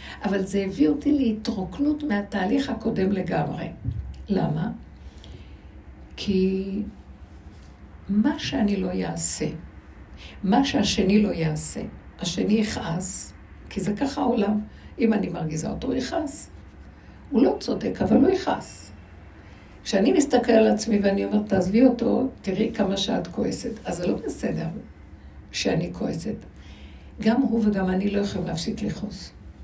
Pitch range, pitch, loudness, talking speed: 175-230 Hz, 205 Hz, -24 LUFS, 130 wpm